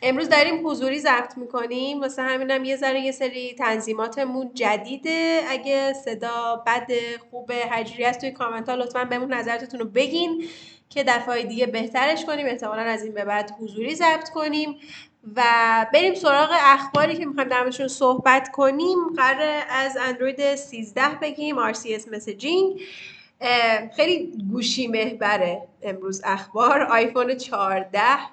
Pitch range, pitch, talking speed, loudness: 230-280 Hz, 255 Hz, 135 wpm, -22 LUFS